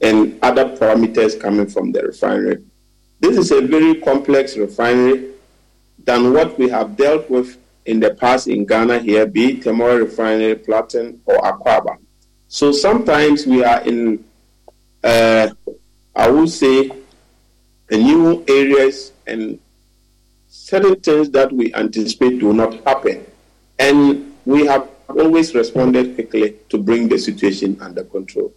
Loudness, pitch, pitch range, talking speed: -15 LUFS, 125 Hz, 110-140 Hz, 135 wpm